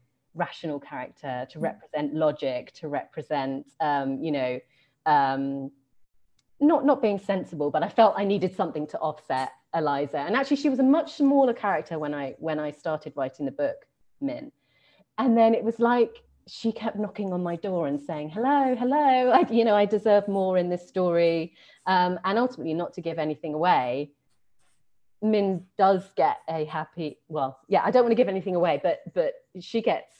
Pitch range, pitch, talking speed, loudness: 150-225 Hz, 180 Hz, 180 wpm, -26 LUFS